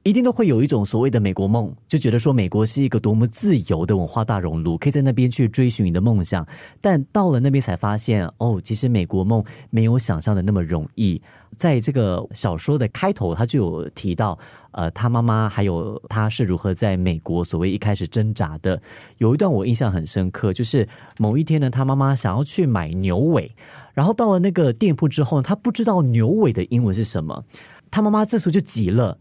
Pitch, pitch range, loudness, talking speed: 115 Hz, 95-140 Hz, -20 LUFS, 325 characters per minute